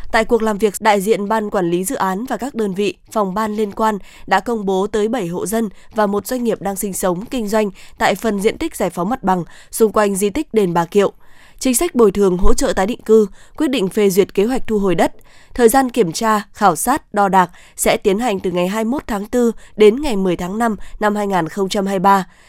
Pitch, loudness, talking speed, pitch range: 210 Hz, -17 LUFS, 245 wpm, 195-225 Hz